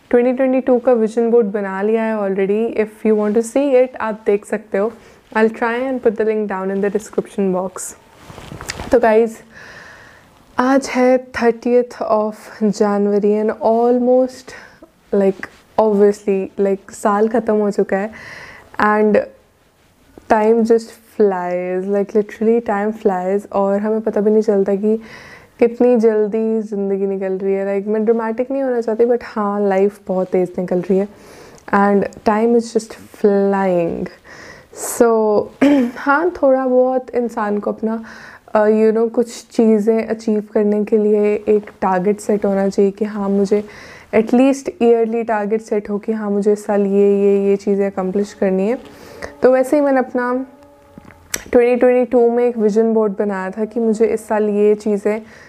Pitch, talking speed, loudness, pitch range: 215 Hz, 160 wpm, -16 LUFS, 205-235 Hz